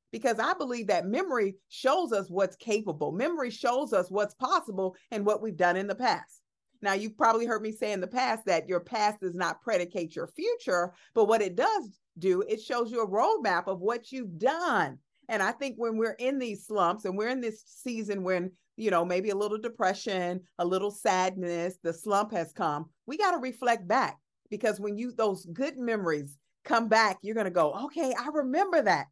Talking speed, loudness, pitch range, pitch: 205 wpm, -29 LUFS, 185-245 Hz, 215 Hz